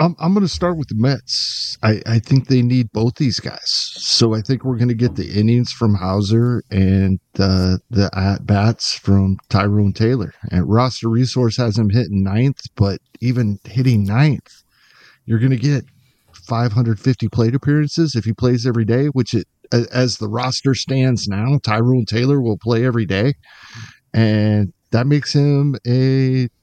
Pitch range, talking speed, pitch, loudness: 105-130 Hz, 170 wpm, 120 Hz, -17 LUFS